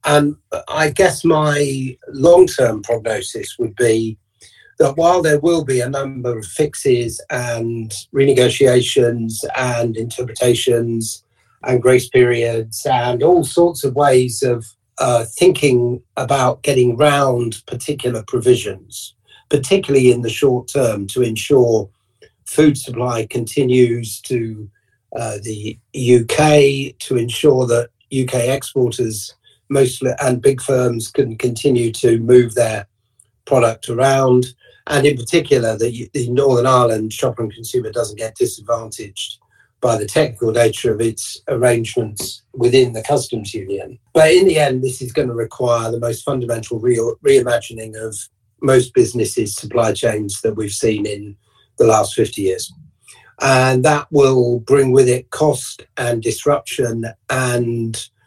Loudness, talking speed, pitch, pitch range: -16 LUFS, 135 wpm, 125 Hz, 115-135 Hz